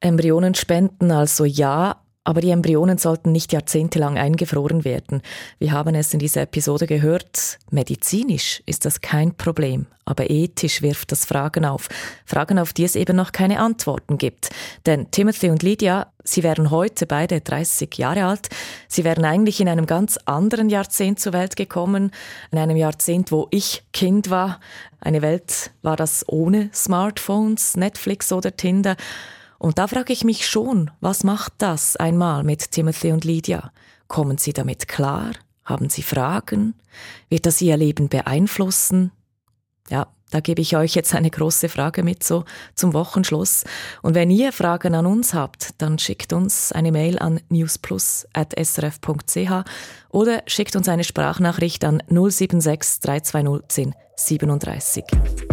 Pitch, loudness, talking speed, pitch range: 165 Hz, -20 LUFS, 150 wpm, 150-185 Hz